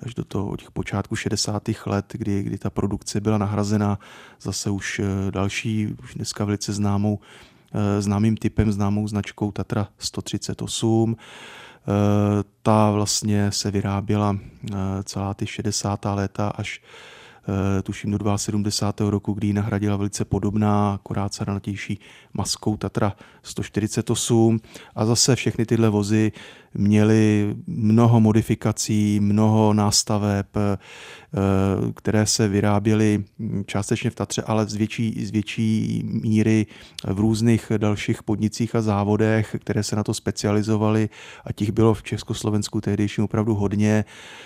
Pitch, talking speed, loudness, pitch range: 105 Hz, 120 wpm, -22 LUFS, 100-110 Hz